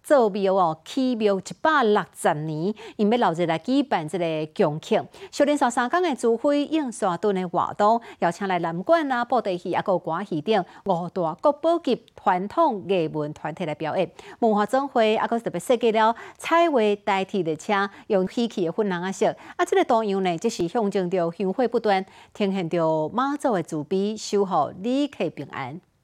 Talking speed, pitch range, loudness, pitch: 270 characters per minute, 180-245 Hz, -24 LUFS, 205 Hz